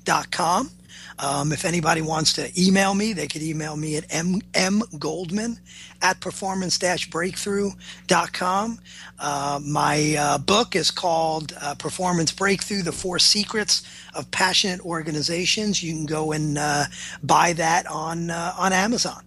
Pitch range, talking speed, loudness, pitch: 155-190 Hz, 140 wpm, -22 LUFS, 170 Hz